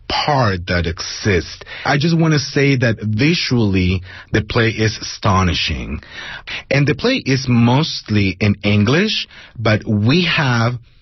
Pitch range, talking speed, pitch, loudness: 105-140 Hz, 130 wpm, 115 Hz, -16 LUFS